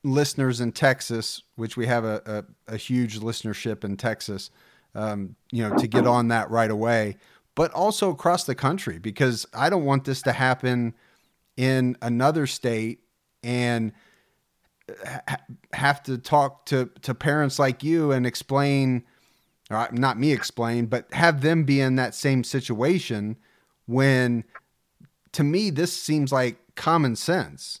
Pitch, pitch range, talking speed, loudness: 125 Hz, 115-140 Hz, 150 wpm, -24 LUFS